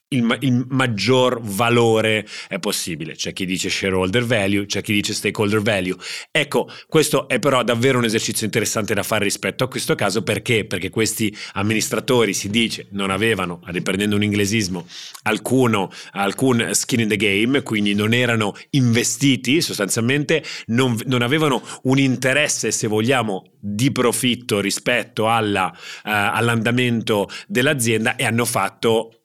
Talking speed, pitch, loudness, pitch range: 145 wpm, 115 Hz, -19 LUFS, 105-125 Hz